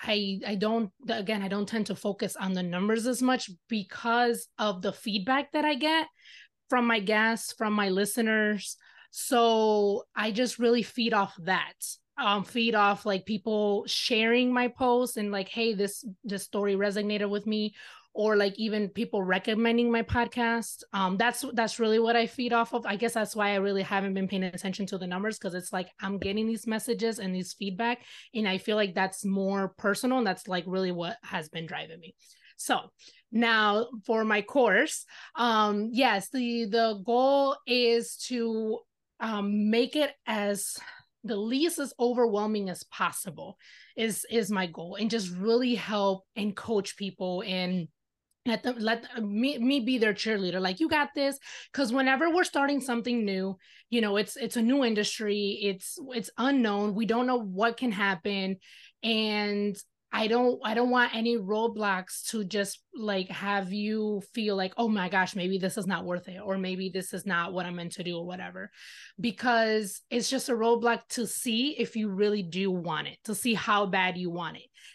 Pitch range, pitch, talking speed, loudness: 195-235 Hz, 215 Hz, 185 wpm, -28 LUFS